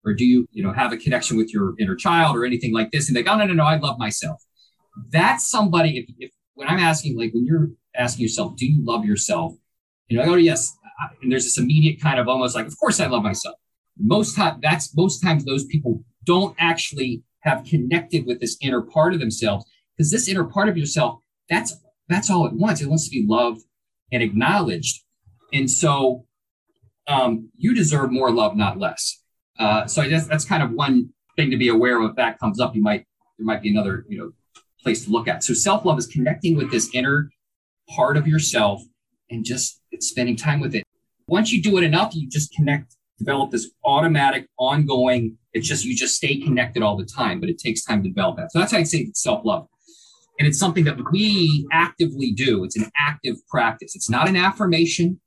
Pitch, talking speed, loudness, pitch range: 145 Hz, 215 wpm, -20 LUFS, 120-165 Hz